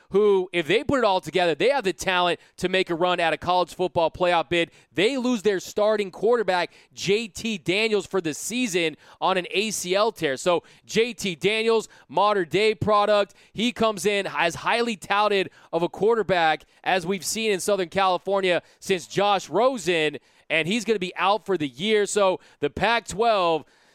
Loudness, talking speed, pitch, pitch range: -23 LUFS, 180 wpm, 190 Hz, 175-210 Hz